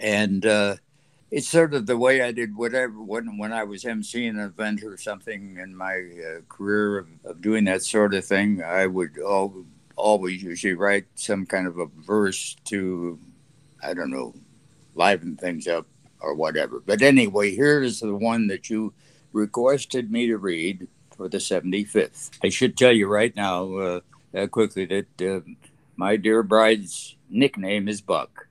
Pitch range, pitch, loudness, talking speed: 95-115 Hz, 105 Hz, -23 LUFS, 170 wpm